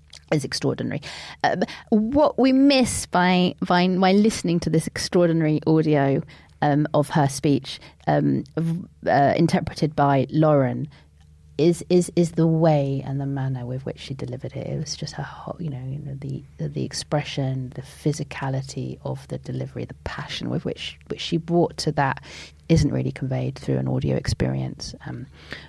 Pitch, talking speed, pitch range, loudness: 145 Hz, 165 wpm, 130-170 Hz, -23 LUFS